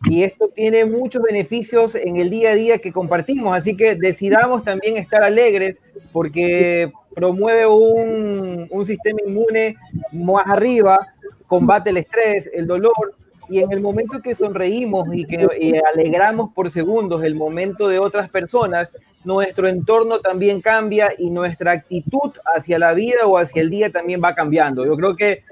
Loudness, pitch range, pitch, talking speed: -17 LUFS, 175-220 Hz, 195 Hz, 160 wpm